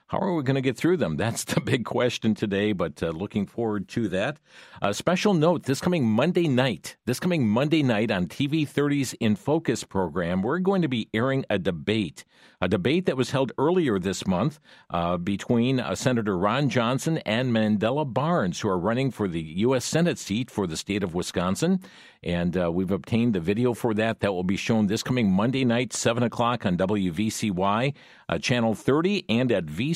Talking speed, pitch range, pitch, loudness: 200 wpm, 105-140 Hz, 120 Hz, -25 LUFS